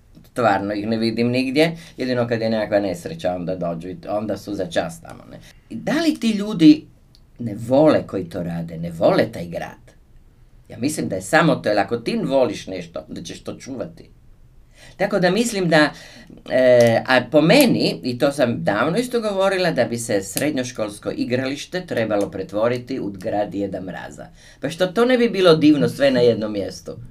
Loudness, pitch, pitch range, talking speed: -19 LUFS, 125 Hz, 105-165 Hz, 185 wpm